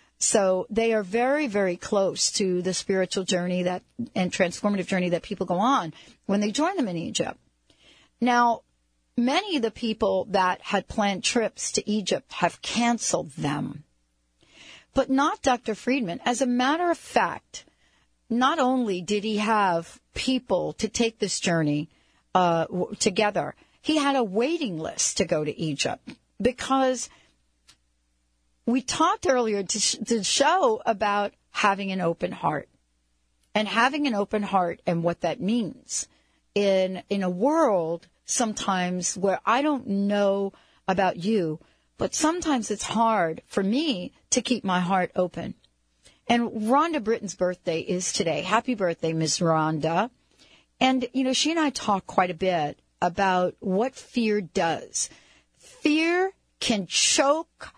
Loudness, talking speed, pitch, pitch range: -25 LUFS, 145 wpm, 205 Hz, 180-245 Hz